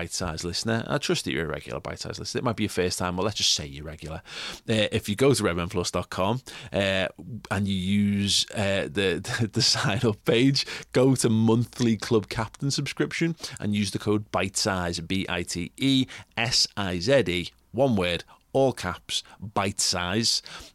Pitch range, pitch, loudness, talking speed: 90-120 Hz, 105 Hz, -25 LUFS, 190 wpm